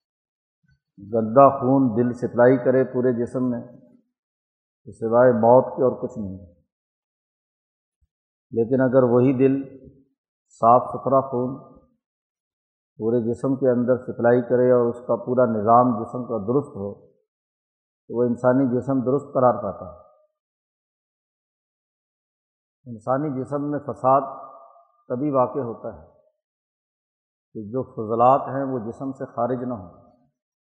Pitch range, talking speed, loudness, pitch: 120-135 Hz, 125 wpm, -21 LUFS, 125 Hz